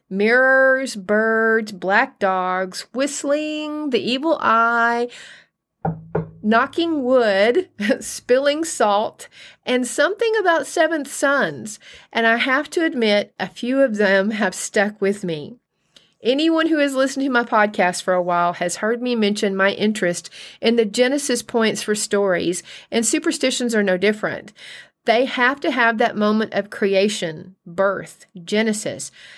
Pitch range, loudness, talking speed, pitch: 200-265 Hz, -19 LUFS, 135 wpm, 225 Hz